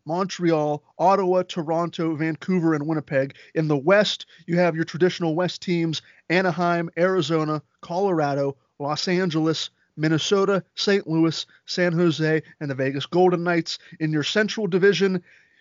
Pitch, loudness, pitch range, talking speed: 170 Hz, -23 LUFS, 155-185 Hz, 130 wpm